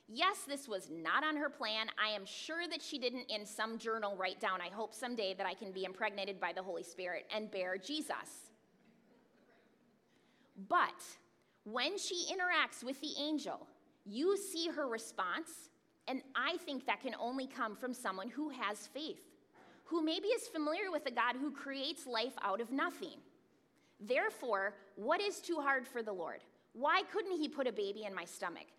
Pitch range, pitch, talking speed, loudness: 215-320 Hz, 255 Hz, 180 wpm, -39 LUFS